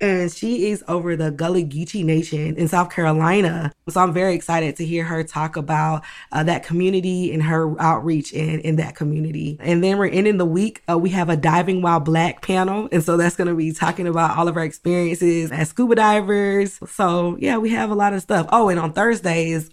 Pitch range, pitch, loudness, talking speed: 160-185 Hz, 170 Hz, -20 LUFS, 215 wpm